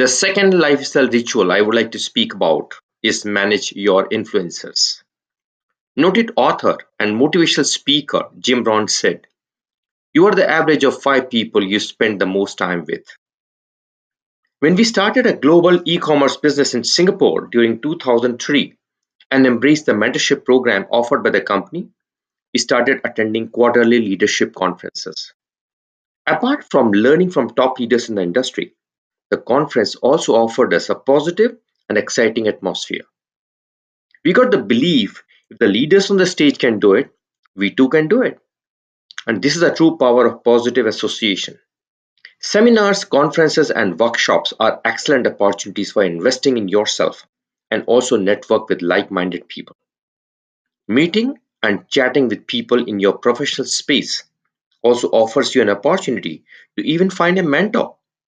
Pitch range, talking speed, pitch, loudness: 110-160 Hz, 150 wpm, 125 Hz, -15 LUFS